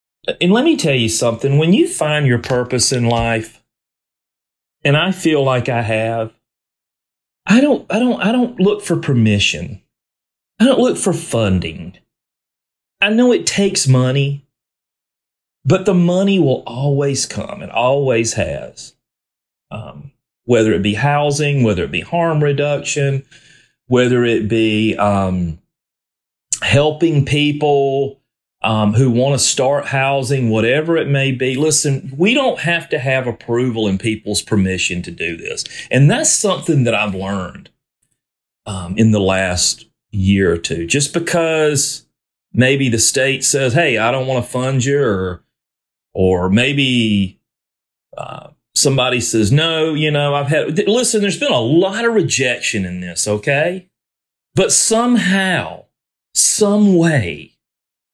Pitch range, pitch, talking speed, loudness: 110-160 Hz, 135 Hz, 140 wpm, -15 LUFS